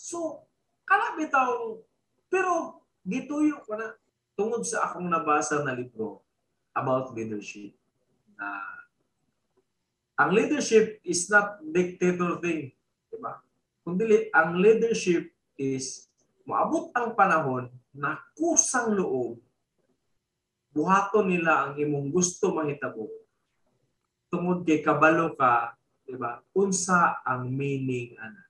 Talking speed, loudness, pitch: 105 wpm, -26 LUFS, 175 Hz